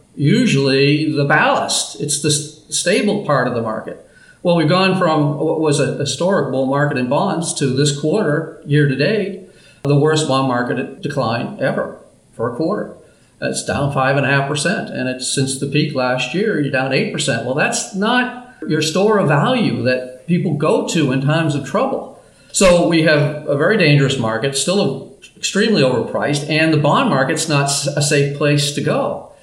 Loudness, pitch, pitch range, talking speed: -16 LUFS, 150 Hz, 140-170 Hz, 185 wpm